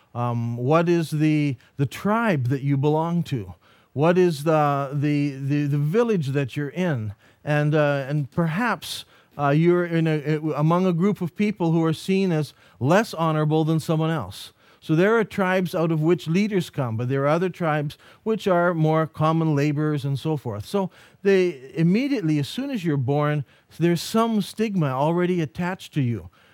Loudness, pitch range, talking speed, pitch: -23 LUFS, 145-175 Hz, 180 wpm, 155 Hz